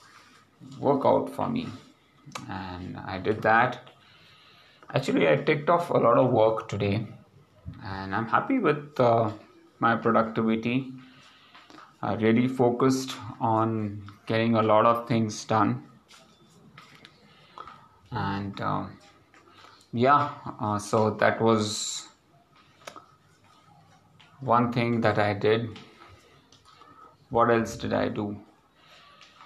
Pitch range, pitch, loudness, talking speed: 105-130 Hz, 115 Hz, -25 LUFS, 100 wpm